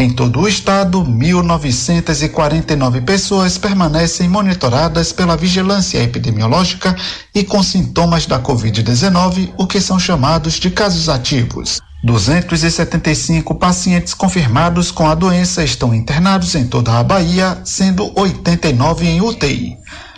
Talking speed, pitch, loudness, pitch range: 115 wpm, 170 Hz, -13 LUFS, 140-185 Hz